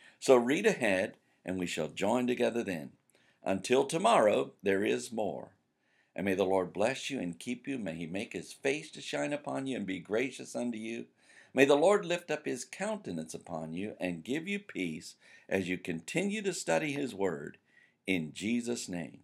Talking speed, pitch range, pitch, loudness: 185 wpm, 90-140 Hz, 115 Hz, -32 LUFS